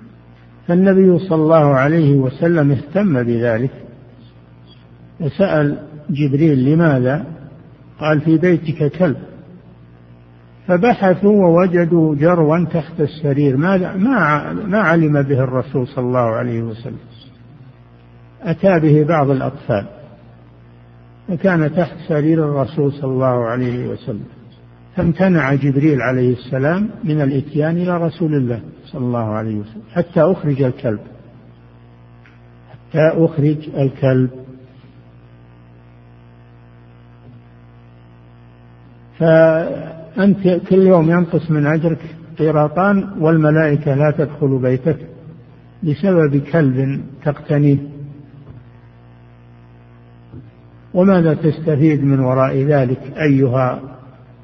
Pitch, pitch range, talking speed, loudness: 140 Hz, 110-160 Hz, 85 wpm, -15 LUFS